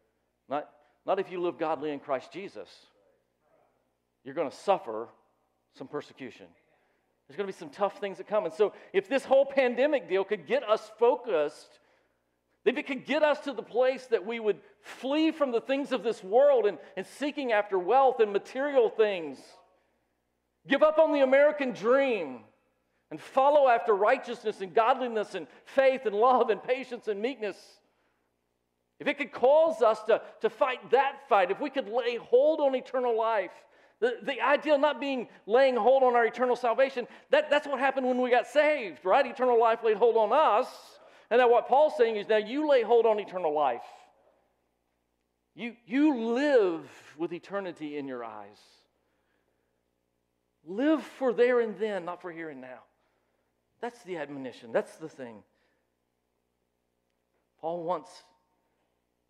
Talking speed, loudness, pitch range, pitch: 165 wpm, -27 LUFS, 165-275 Hz, 230 Hz